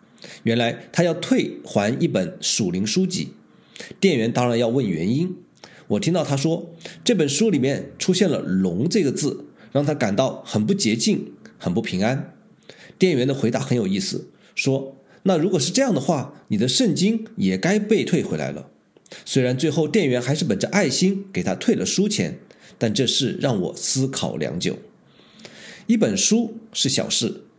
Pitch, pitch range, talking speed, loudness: 180 Hz, 135-205 Hz, 240 characters per minute, -21 LUFS